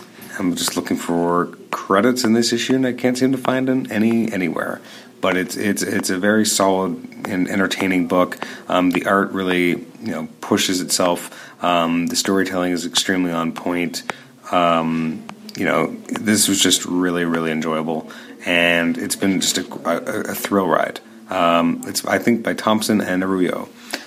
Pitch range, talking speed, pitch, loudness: 85-110 Hz, 165 wpm, 90 Hz, -19 LUFS